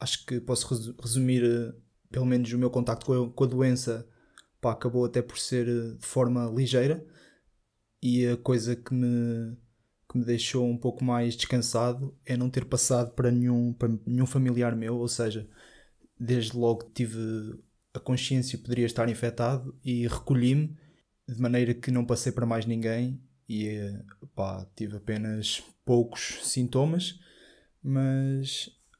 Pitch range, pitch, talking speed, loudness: 115-125 Hz, 120 Hz, 145 wpm, -28 LUFS